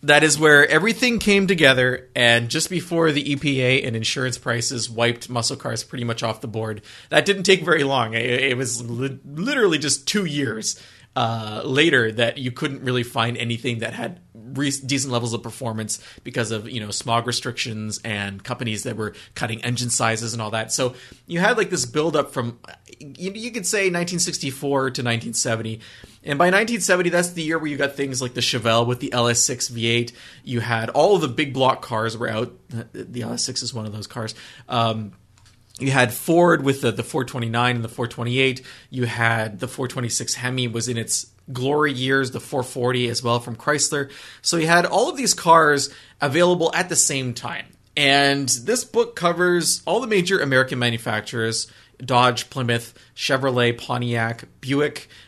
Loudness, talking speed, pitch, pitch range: -21 LUFS, 180 wpm, 125 Hz, 115-145 Hz